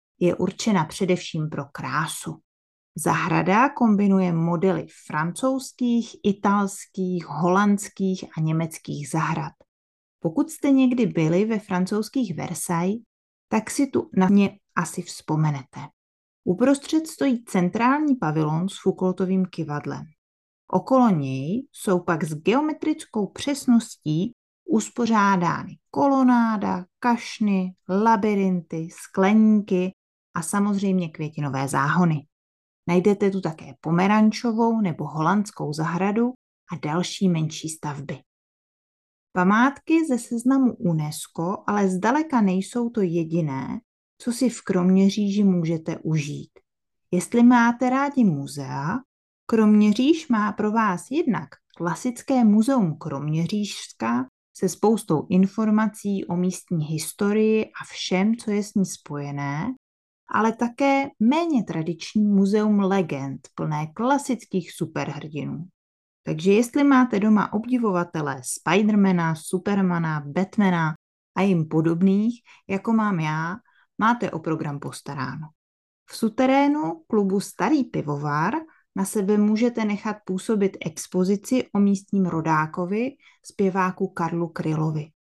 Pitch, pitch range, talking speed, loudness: 190 Hz, 165-225 Hz, 105 wpm, -23 LUFS